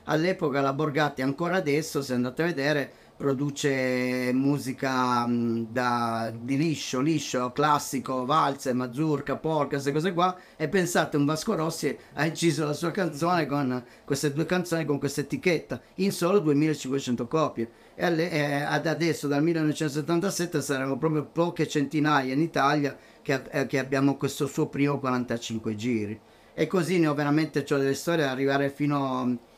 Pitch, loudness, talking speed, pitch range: 145 Hz, -27 LUFS, 155 wpm, 135-155 Hz